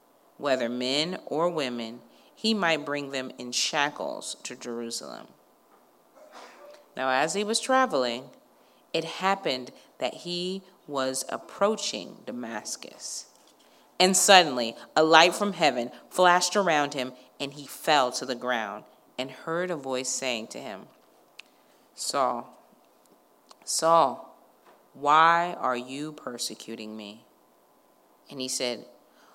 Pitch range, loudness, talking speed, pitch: 125-175 Hz, -26 LUFS, 115 wpm, 145 Hz